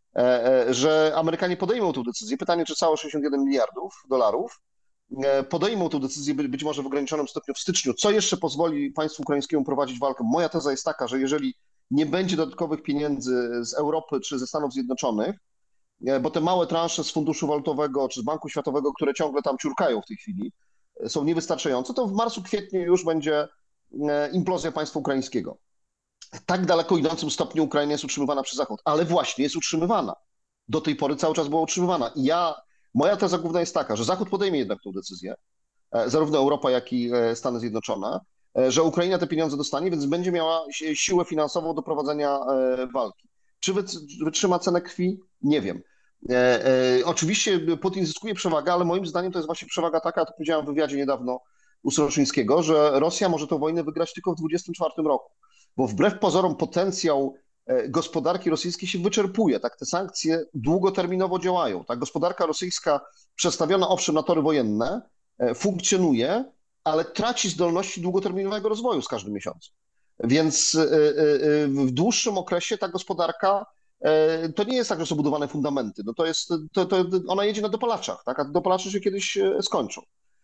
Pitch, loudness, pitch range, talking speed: 165 Hz, -25 LUFS, 145-185 Hz, 165 wpm